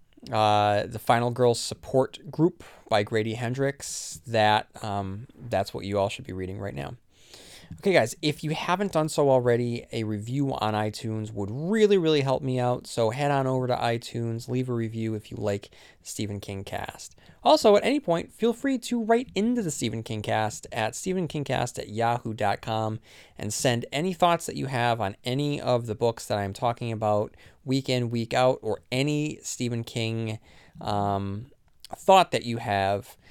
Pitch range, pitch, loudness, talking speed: 105-140 Hz, 120 Hz, -26 LUFS, 180 wpm